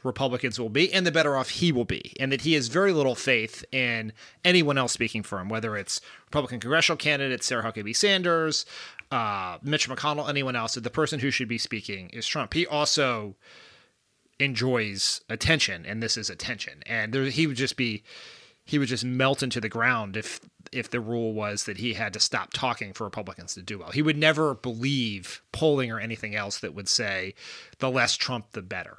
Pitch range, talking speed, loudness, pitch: 110-140 Hz, 200 wpm, -26 LUFS, 125 Hz